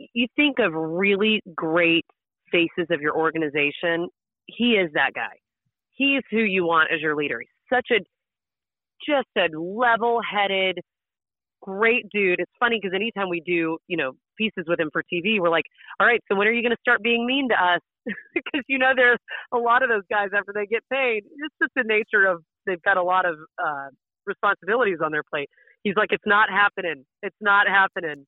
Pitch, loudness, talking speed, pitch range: 200 Hz, -22 LUFS, 195 wpm, 170-235 Hz